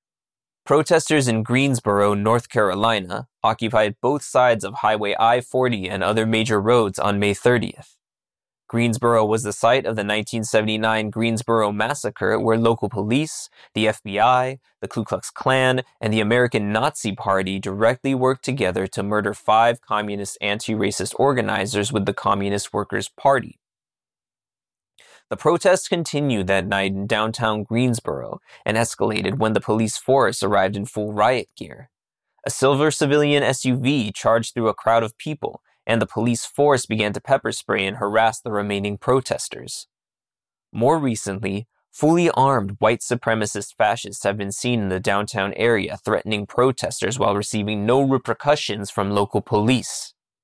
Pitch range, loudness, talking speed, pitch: 100-125 Hz, -21 LUFS, 145 wpm, 110 Hz